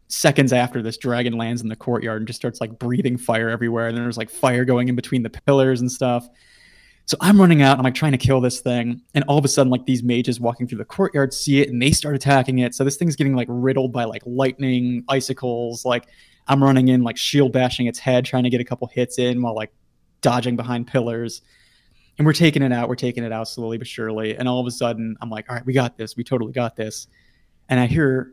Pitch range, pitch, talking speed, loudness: 120-135 Hz, 125 Hz, 255 wpm, -20 LUFS